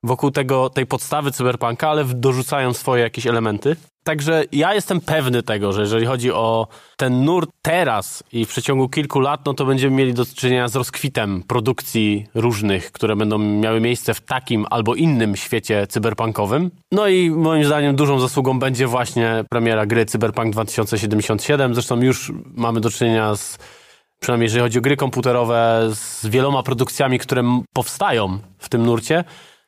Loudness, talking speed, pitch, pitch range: -19 LUFS, 160 wpm, 125 Hz, 115-140 Hz